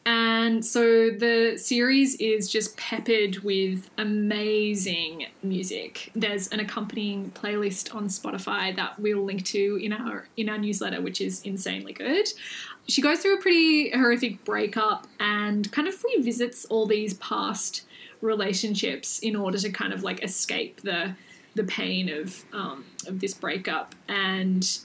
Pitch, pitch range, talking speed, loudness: 210 Hz, 195-230 Hz, 145 wpm, -26 LUFS